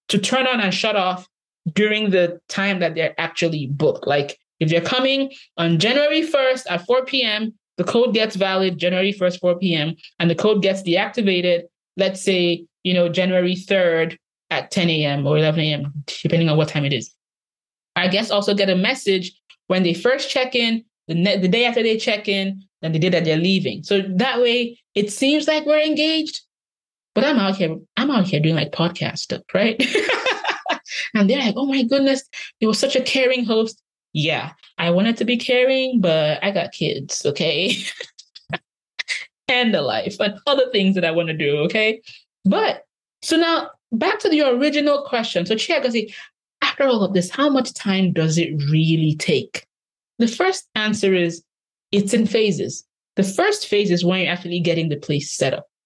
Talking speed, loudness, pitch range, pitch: 185 wpm, -19 LUFS, 170-245 Hz, 195 Hz